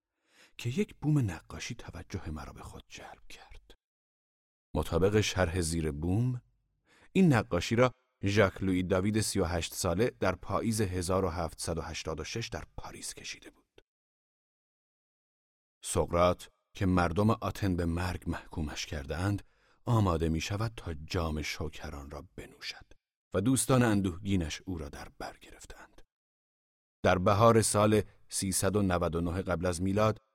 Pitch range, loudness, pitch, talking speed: 85-105 Hz, -31 LUFS, 95 Hz, 120 wpm